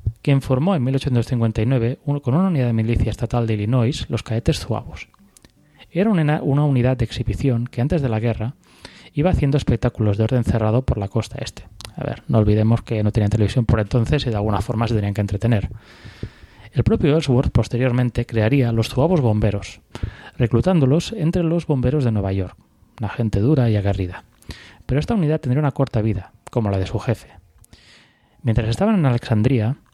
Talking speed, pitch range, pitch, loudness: 180 wpm, 110-135 Hz, 120 Hz, -20 LUFS